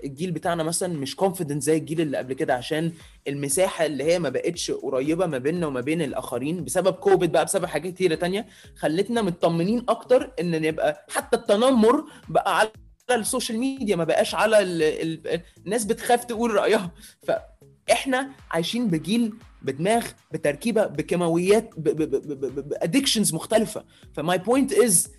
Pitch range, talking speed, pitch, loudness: 160-230 Hz, 160 wpm, 190 Hz, -24 LUFS